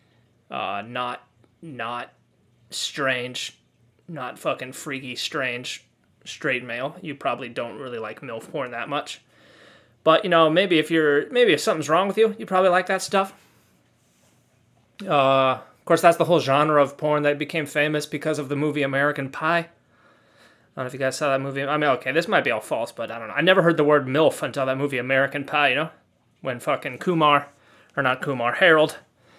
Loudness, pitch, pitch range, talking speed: -22 LUFS, 145 Hz, 130-165 Hz, 195 wpm